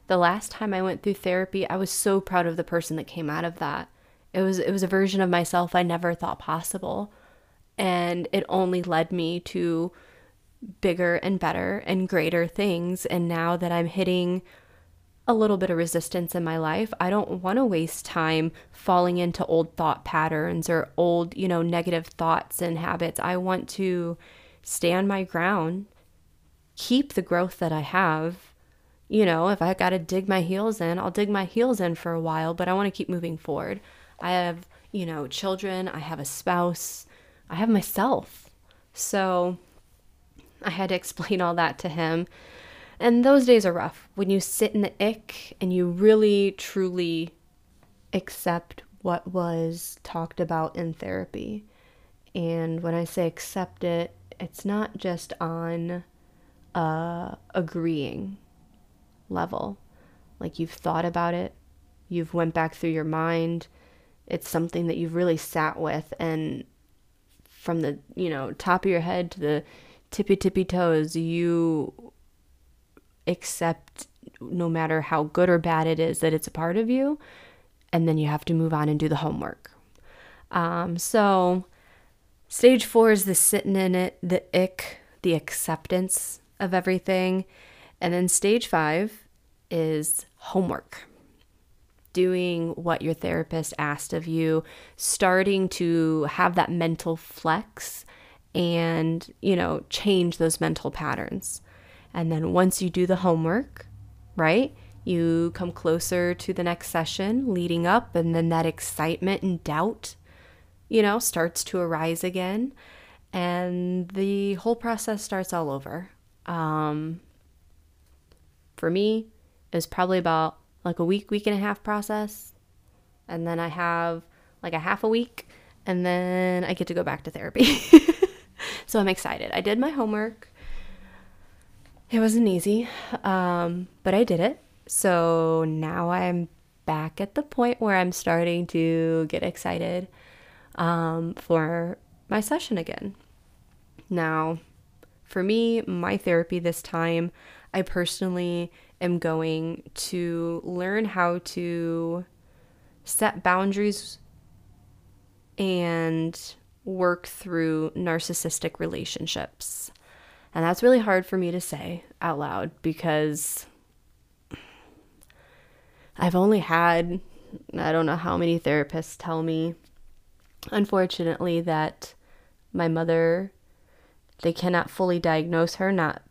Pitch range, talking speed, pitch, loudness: 160-185 Hz, 145 wpm, 170 Hz, -25 LUFS